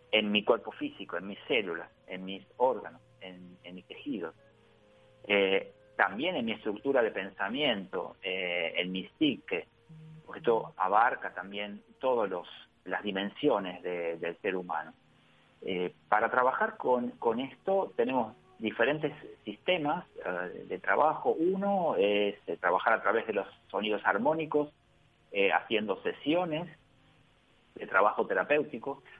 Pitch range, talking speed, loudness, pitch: 100-155 Hz, 125 wpm, -31 LUFS, 115 Hz